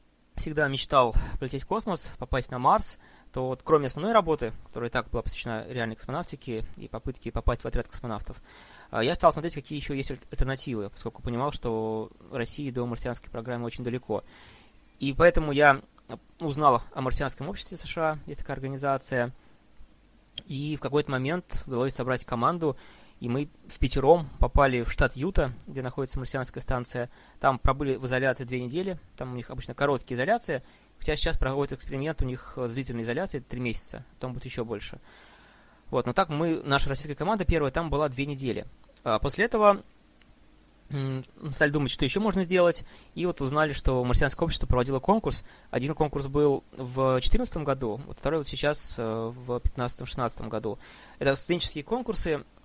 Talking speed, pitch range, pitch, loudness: 165 wpm, 120-150 Hz, 135 Hz, -28 LUFS